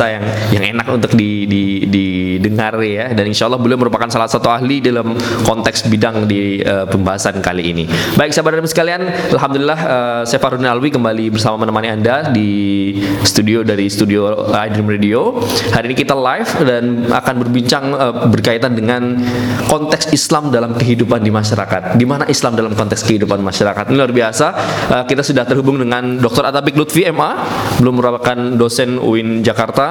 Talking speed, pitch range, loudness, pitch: 165 wpm, 105-125 Hz, -13 LUFS, 115 Hz